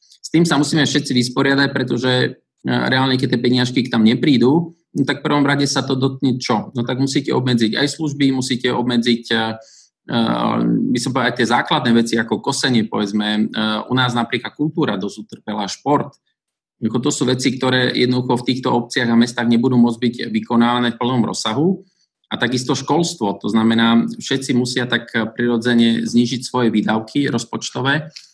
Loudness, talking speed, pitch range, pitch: -17 LUFS, 165 wpm, 115-140 Hz, 125 Hz